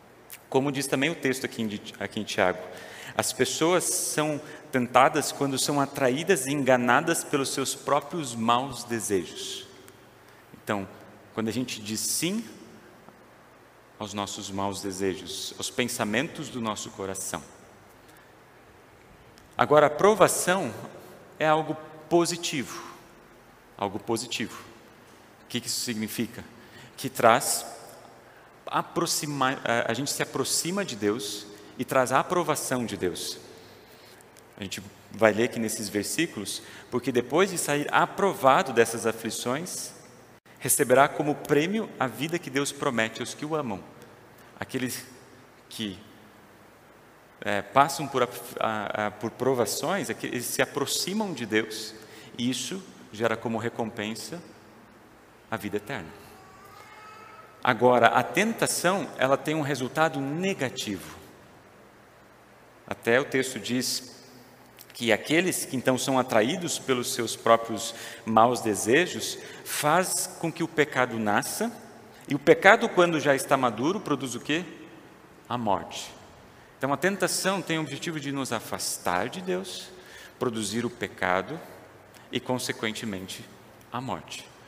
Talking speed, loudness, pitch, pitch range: 120 wpm, -27 LUFS, 125 Hz, 110-150 Hz